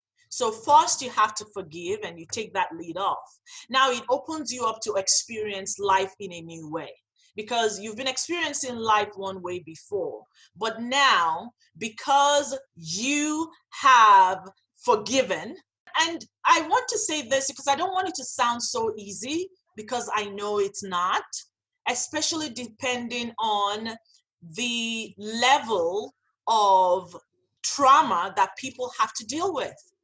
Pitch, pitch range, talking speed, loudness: 245 Hz, 210-305 Hz, 140 wpm, -24 LUFS